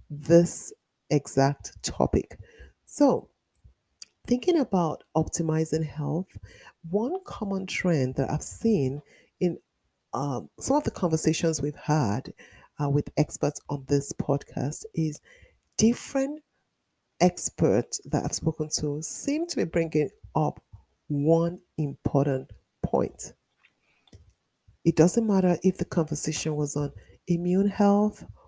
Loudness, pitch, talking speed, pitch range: -26 LUFS, 160 Hz, 110 wpm, 150-195 Hz